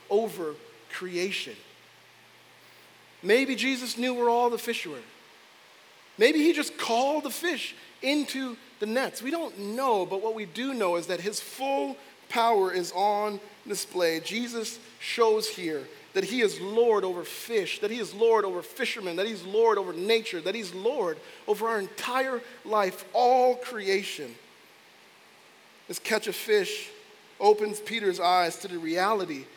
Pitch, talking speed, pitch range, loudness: 230 Hz, 150 wpm, 200-265 Hz, -28 LUFS